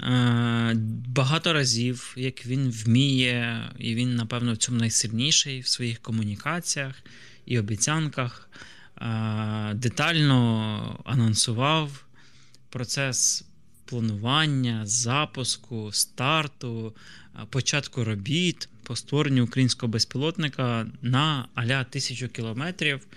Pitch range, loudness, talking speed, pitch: 115-135 Hz, -25 LUFS, 85 wpm, 125 Hz